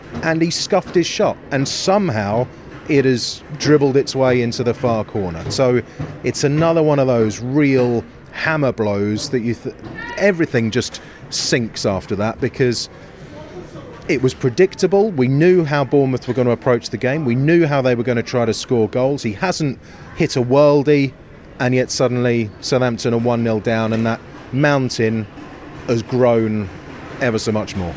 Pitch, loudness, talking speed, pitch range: 125 Hz, -17 LUFS, 170 wpm, 115-145 Hz